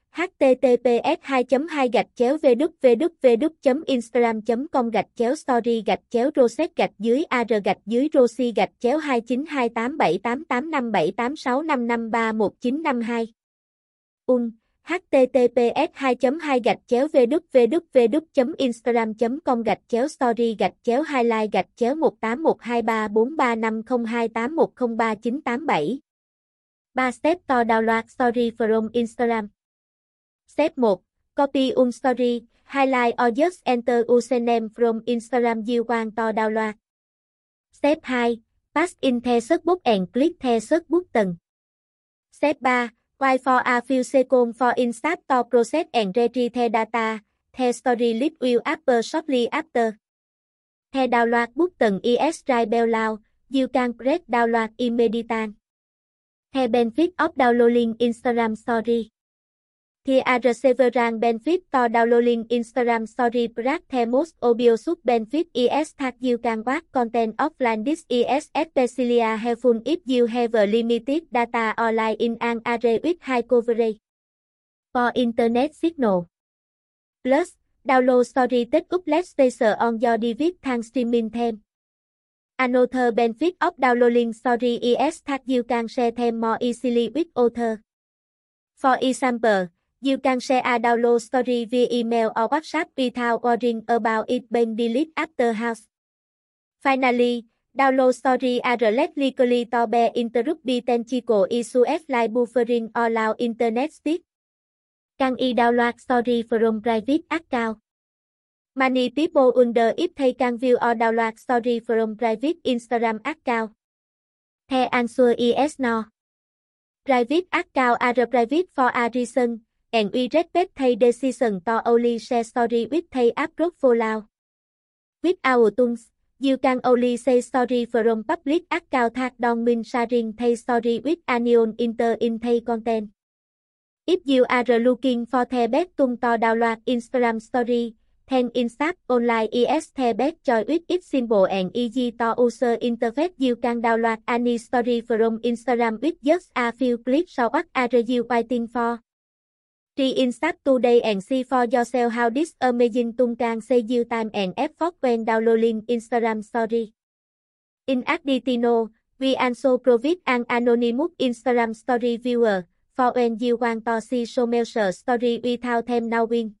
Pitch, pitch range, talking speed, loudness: 245 Hz, 235-260 Hz, 135 wpm, -22 LUFS